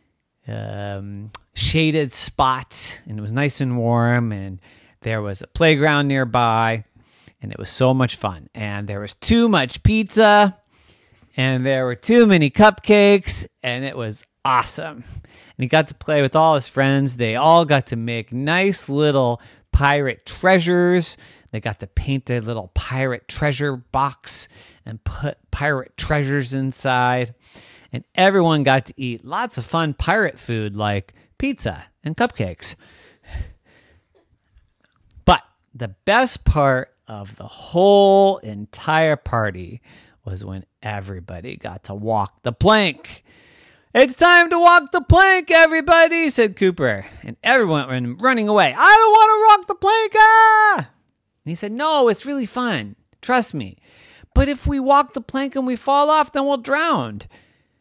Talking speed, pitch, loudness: 150 wpm, 135 Hz, -17 LUFS